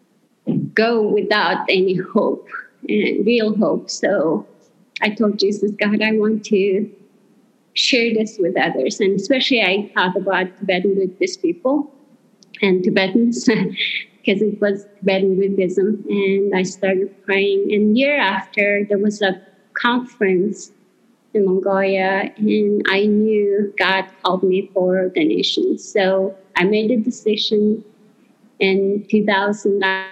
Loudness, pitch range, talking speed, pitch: -18 LUFS, 195-220 Hz, 130 wpm, 205 Hz